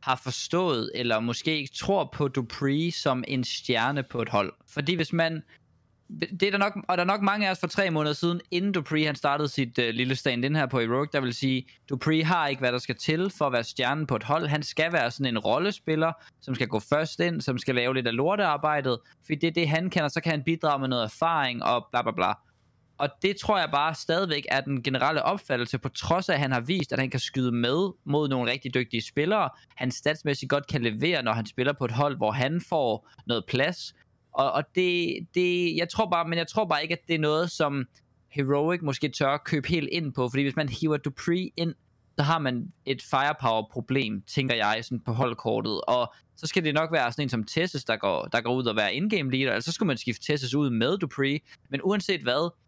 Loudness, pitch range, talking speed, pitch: -27 LUFS, 125-165 Hz, 240 wpm, 145 Hz